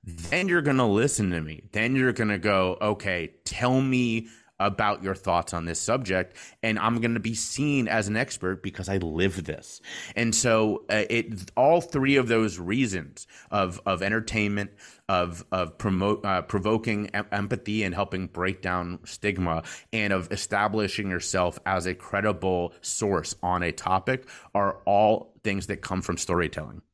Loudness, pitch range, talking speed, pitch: -26 LUFS, 90-110 Hz, 170 wpm, 100 Hz